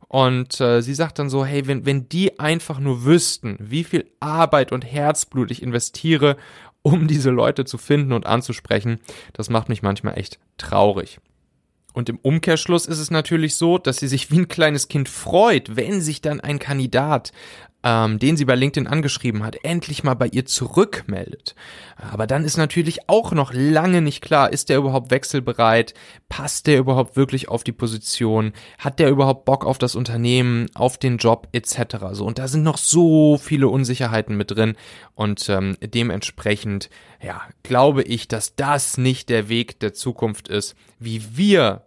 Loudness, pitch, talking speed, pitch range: -19 LUFS, 130 Hz, 175 wpm, 115-145 Hz